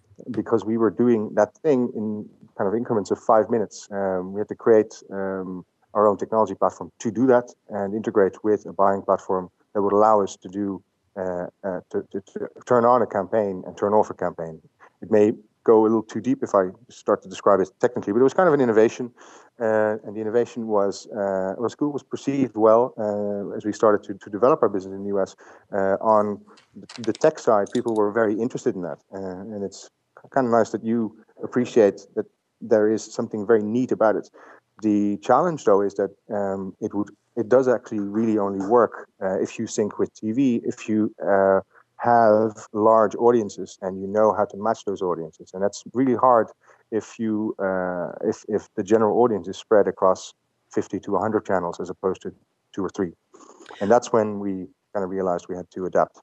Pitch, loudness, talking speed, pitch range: 105 Hz, -23 LUFS, 210 wpm, 95-110 Hz